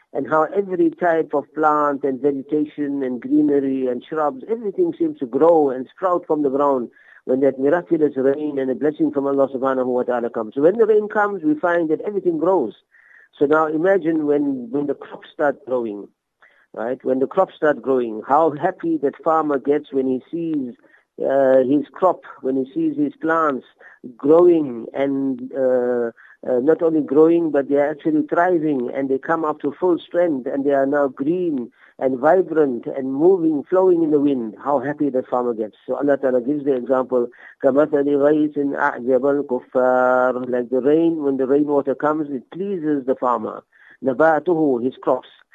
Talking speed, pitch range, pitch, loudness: 175 wpm, 130-160 Hz, 145 Hz, -19 LUFS